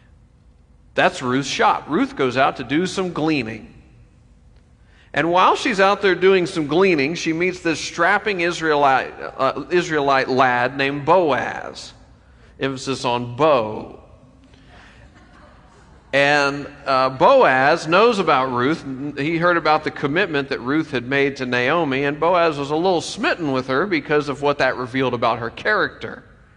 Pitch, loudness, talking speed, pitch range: 145 Hz, -19 LUFS, 145 wpm, 130-170 Hz